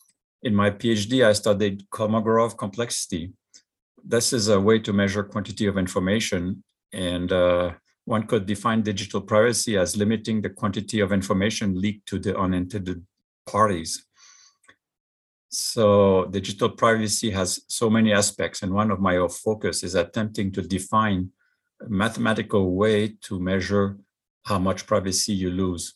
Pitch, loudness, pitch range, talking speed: 100 Hz, -23 LUFS, 95-110 Hz, 140 wpm